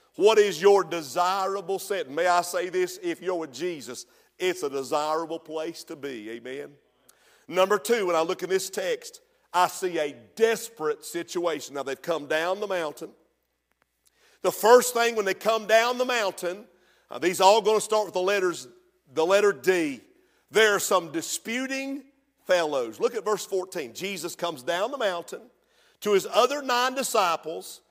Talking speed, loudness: 170 wpm, -25 LUFS